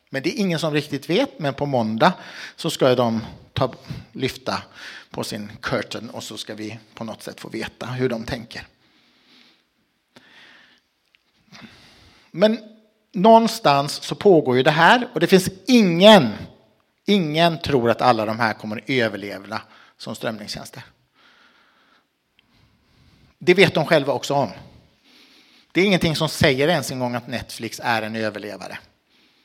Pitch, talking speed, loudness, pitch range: 140 Hz, 145 wpm, -20 LUFS, 115-180 Hz